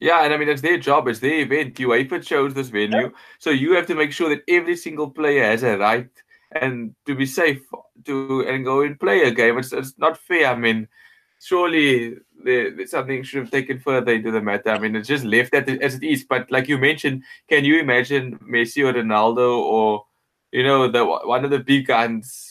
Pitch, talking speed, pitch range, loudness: 135 Hz, 225 wpm, 120-150 Hz, -19 LUFS